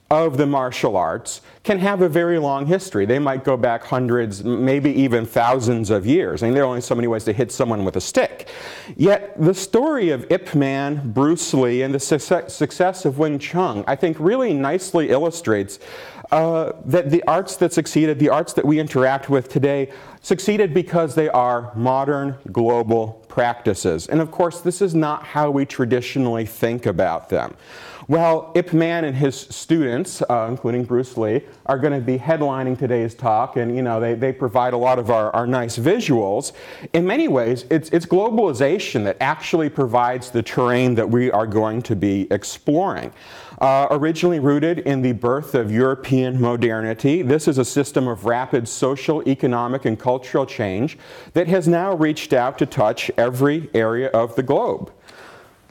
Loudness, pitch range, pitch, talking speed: -19 LUFS, 120-160 Hz, 135 Hz, 180 wpm